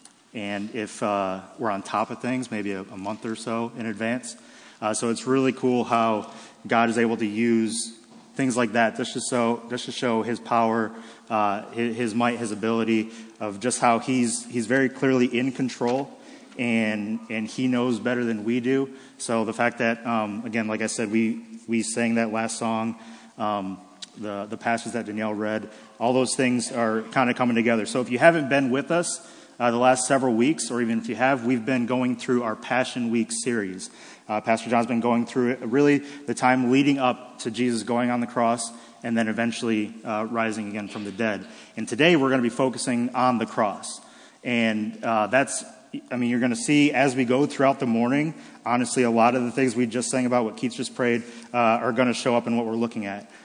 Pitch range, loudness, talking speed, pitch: 115-125 Hz, -24 LUFS, 215 wpm, 120 Hz